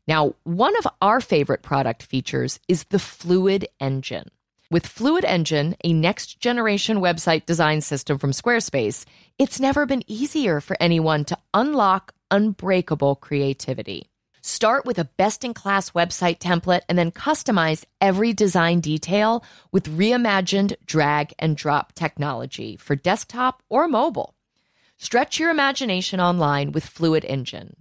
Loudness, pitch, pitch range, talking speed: -21 LUFS, 175 Hz, 155-210 Hz, 135 wpm